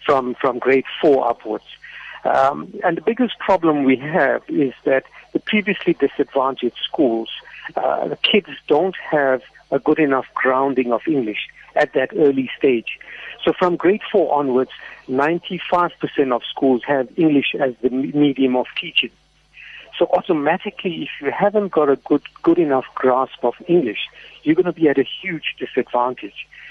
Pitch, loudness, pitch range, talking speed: 145 Hz, -19 LUFS, 130-175 Hz, 155 wpm